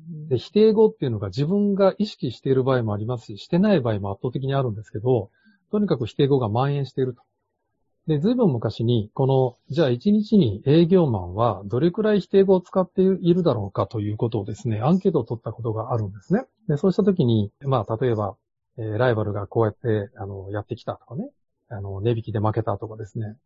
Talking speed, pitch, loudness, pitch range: 440 characters per minute, 125 Hz, -23 LUFS, 110-175 Hz